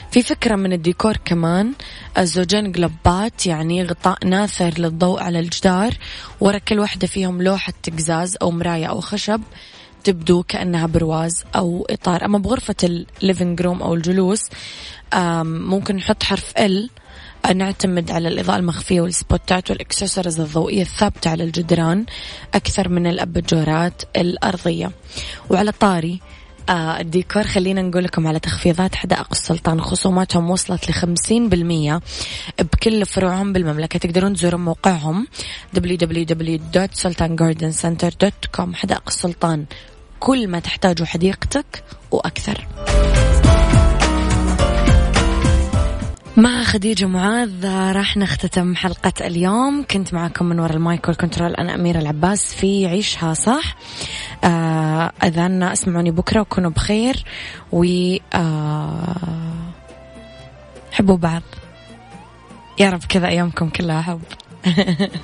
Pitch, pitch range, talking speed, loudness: 180 Hz, 170-195 Hz, 105 wpm, -18 LUFS